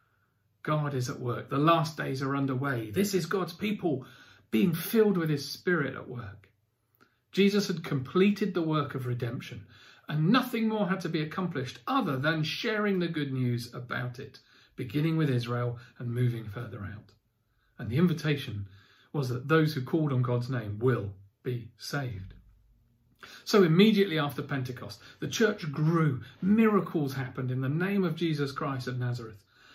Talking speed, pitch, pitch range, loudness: 160 wpm, 135 Hz, 120-165 Hz, -29 LUFS